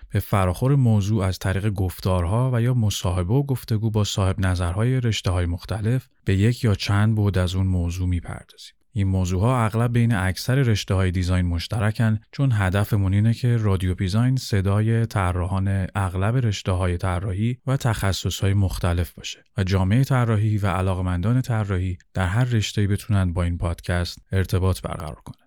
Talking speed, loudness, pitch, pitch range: 165 wpm, -22 LUFS, 100 Hz, 95-115 Hz